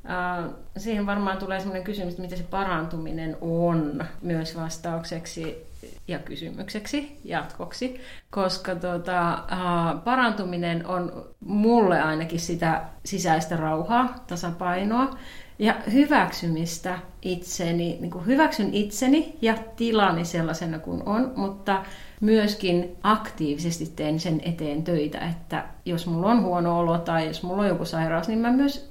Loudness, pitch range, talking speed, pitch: -26 LUFS, 165-210 Hz, 125 wpm, 180 Hz